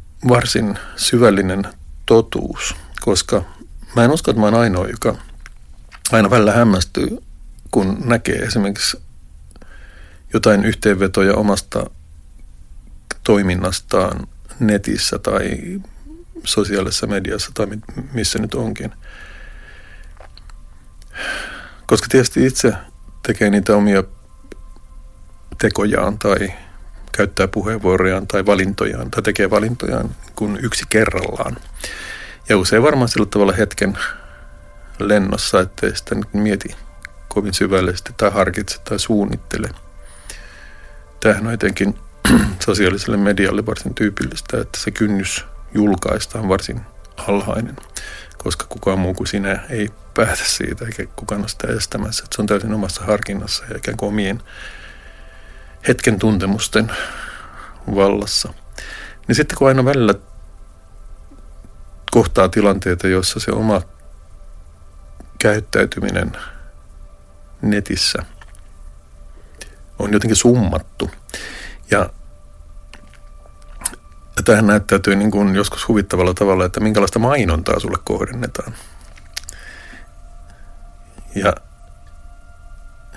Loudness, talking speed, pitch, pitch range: -17 LUFS, 95 wpm, 100 Hz, 75-105 Hz